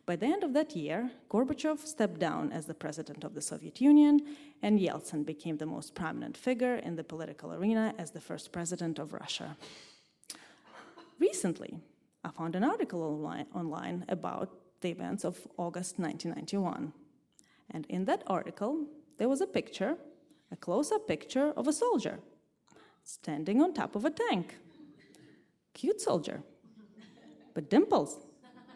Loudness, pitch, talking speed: -33 LUFS, 210 Hz, 145 wpm